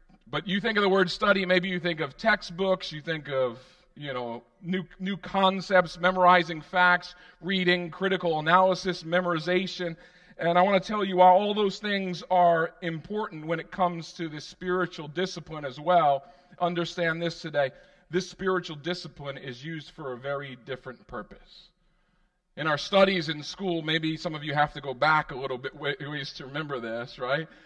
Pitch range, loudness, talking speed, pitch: 155-180 Hz, -27 LUFS, 175 wpm, 180 Hz